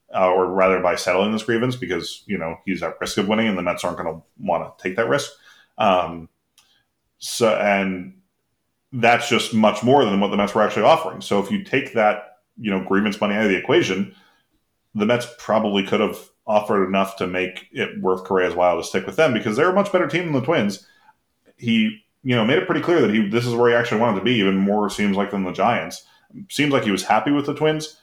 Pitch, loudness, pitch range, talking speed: 105 Hz, -20 LUFS, 95-125 Hz, 240 wpm